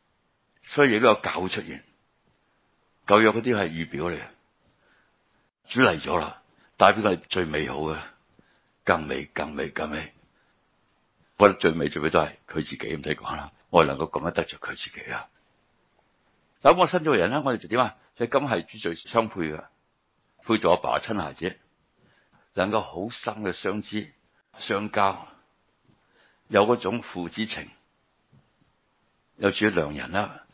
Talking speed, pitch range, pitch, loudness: 215 characters per minute, 90-115 Hz, 105 Hz, -25 LUFS